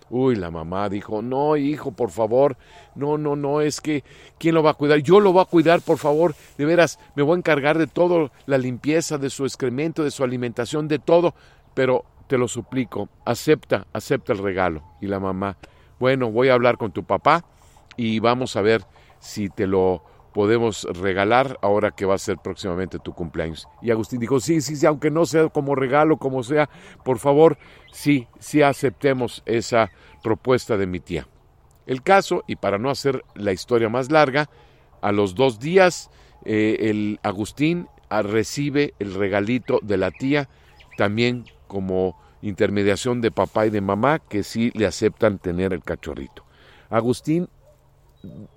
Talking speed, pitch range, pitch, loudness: 175 wpm, 100-150 Hz, 125 Hz, -21 LUFS